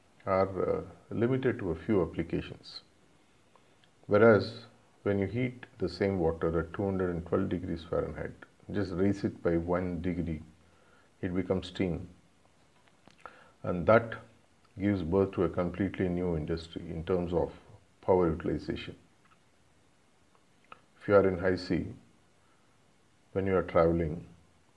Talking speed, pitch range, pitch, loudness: 125 wpm, 85-100 Hz, 95 Hz, -31 LUFS